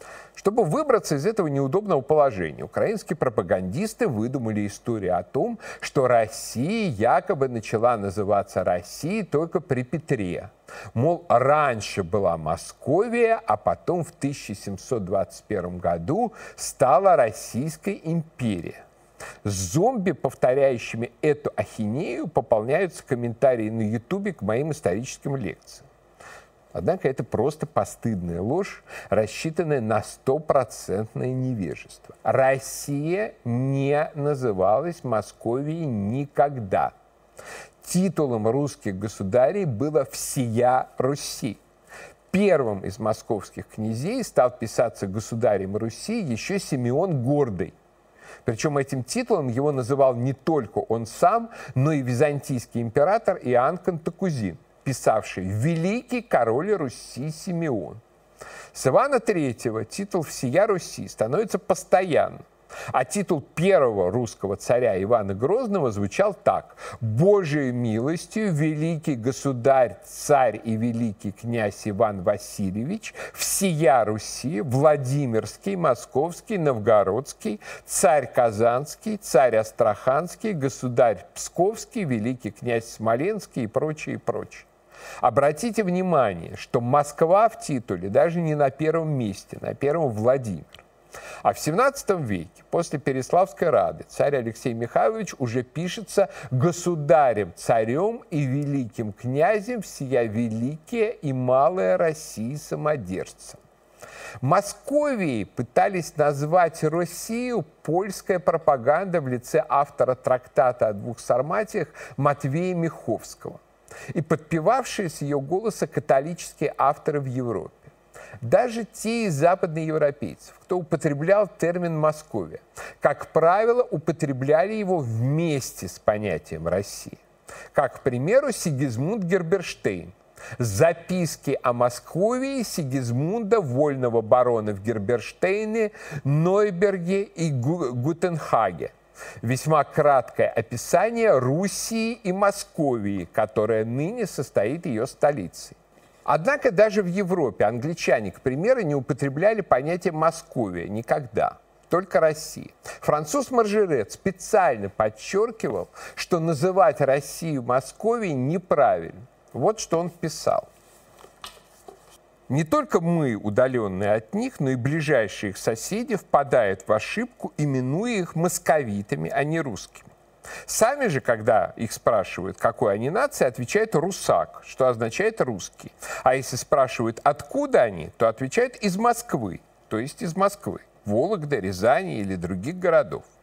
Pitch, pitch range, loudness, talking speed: 145 Hz, 120-180 Hz, -24 LUFS, 105 wpm